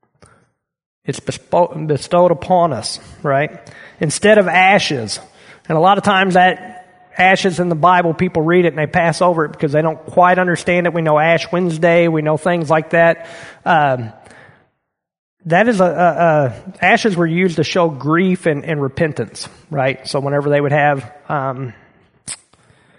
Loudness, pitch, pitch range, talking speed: -15 LUFS, 170 Hz, 150-180 Hz, 165 wpm